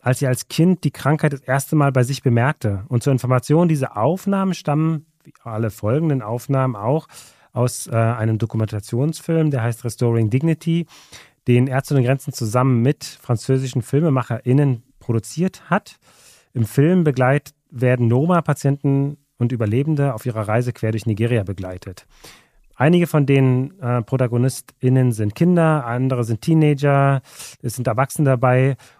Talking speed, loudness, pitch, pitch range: 140 wpm, -19 LUFS, 130 Hz, 120-145 Hz